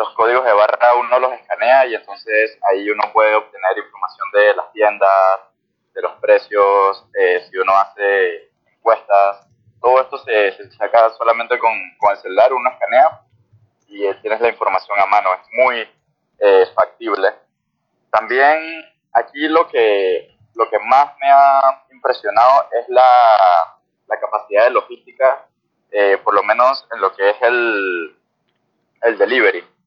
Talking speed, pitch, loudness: 150 wpm, 125 Hz, -15 LUFS